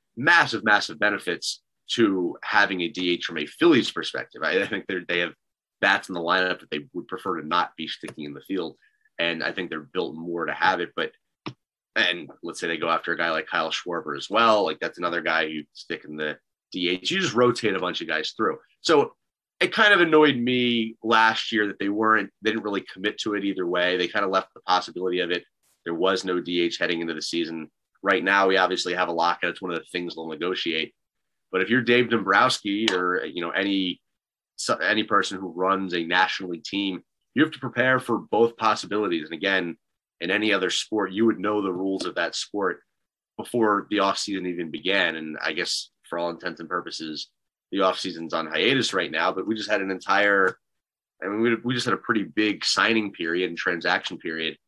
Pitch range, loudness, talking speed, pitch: 85-110 Hz, -24 LUFS, 215 wpm, 95 Hz